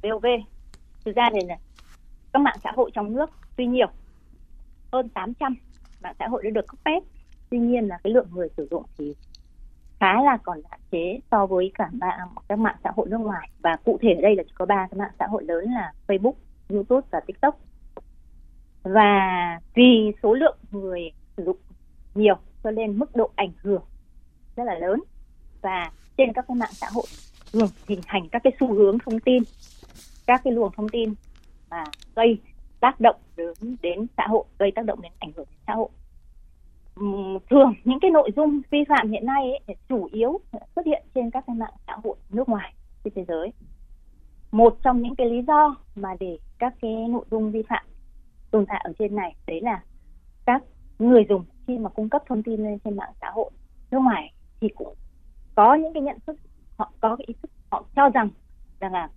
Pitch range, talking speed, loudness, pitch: 190-250 Hz, 205 wpm, -23 LUFS, 220 Hz